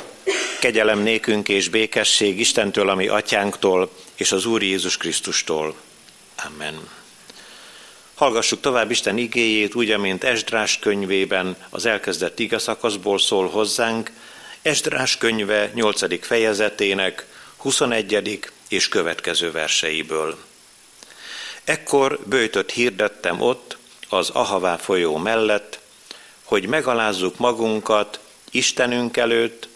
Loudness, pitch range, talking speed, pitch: -20 LUFS, 100-115 Hz, 95 wpm, 110 Hz